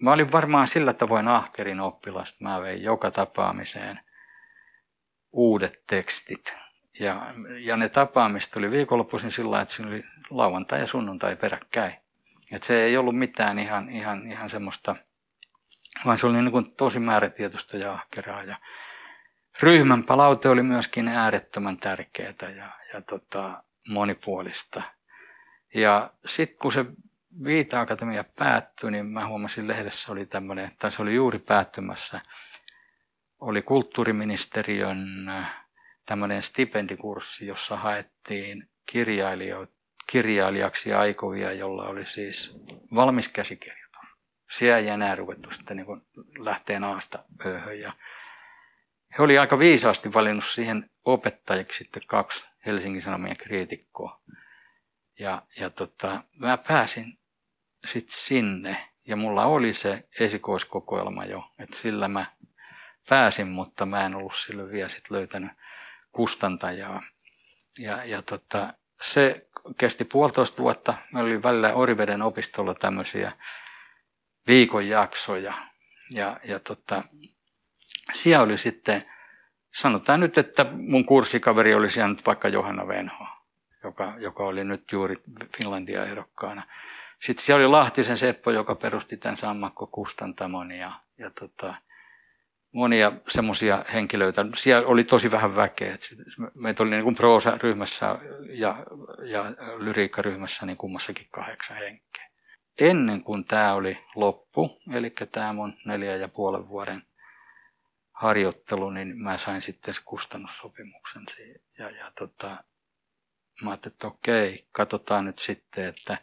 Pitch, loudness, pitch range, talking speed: 110 Hz, -25 LUFS, 100-125 Hz, 120 wpm